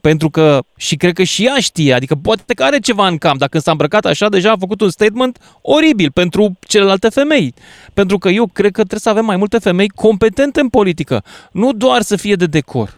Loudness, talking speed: -13 LUFS, 220 wpm